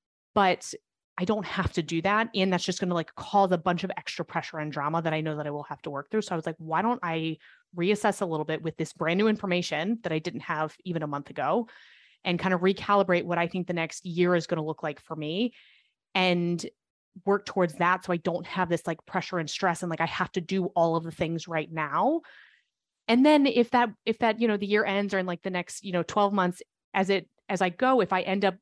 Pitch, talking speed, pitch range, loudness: 180 Hz, 265 wpm, 165-200 Hz, -28 LUFS